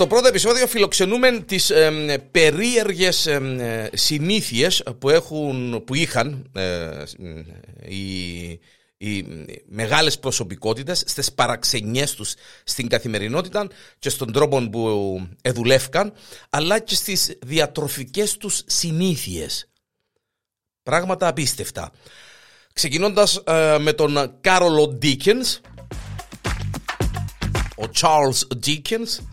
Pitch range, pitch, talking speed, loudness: 120-185 Hz, 150 Hz, 90 wpm, -20 LUFS